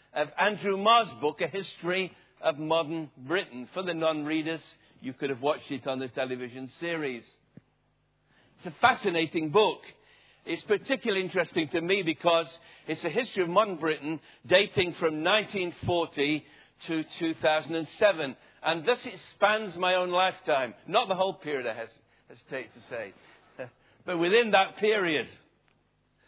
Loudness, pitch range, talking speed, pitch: -28 LUFS, 150-185 Hz, 140 wpm, 165 Hz